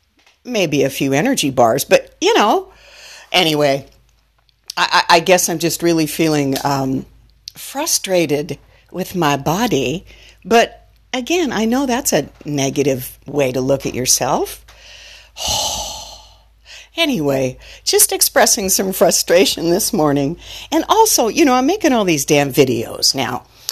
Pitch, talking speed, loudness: 170 Hz, 130 wpm, -15 LUFS